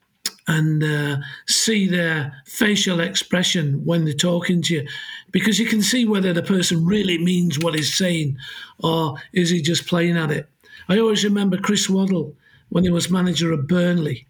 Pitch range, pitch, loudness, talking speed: 155-185 Hz, 175 Hz, -20 LUFS, 170 wpm